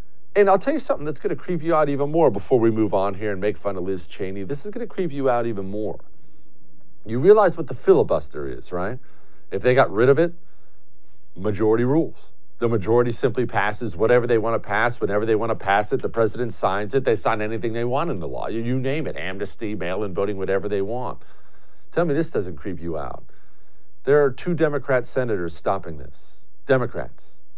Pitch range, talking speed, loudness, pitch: 100-135 Hz, 210 wpm, -22 LUFS, 115 Hz